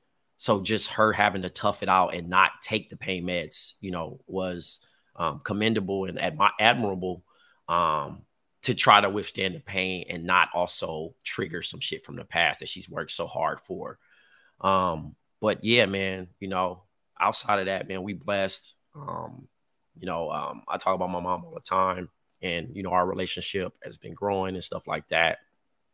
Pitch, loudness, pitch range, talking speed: 95 Hz, -27 LUFS, 90-100 Hz, 185 wpm